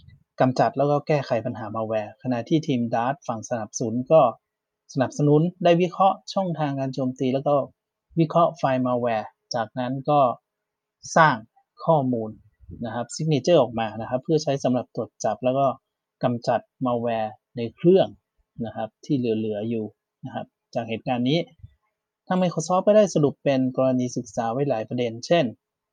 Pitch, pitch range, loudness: 130 Hz, 115-155 Hz, -24 LUFS